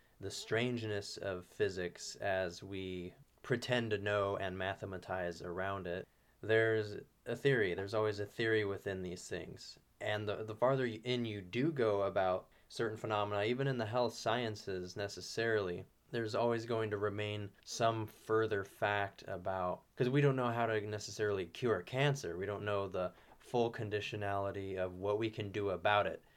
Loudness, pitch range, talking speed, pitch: -37 LUFS, 100-115 Hz, 160 wpm, 105 Hz